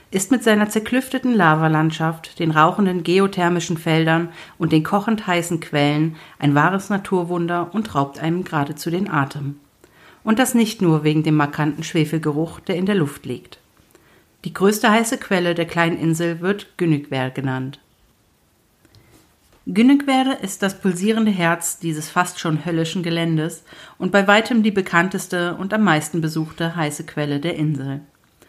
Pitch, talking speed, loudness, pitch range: 170 Hz, 145 wpm, -19 LUFS, 155-195 Hz